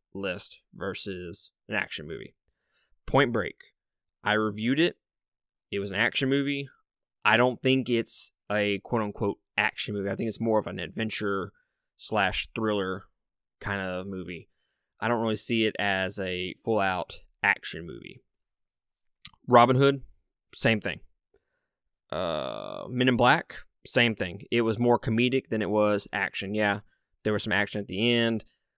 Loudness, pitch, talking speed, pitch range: -27 LUFS, 110 Hz, 150 wpm, 100-120 Hz